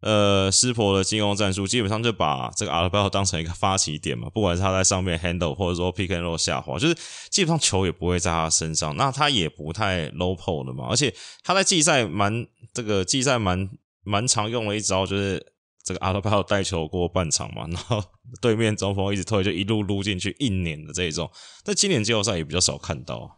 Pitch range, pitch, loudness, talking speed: 90-110 Hz, 100 Hz, -23 LUFS, 380 characters per minute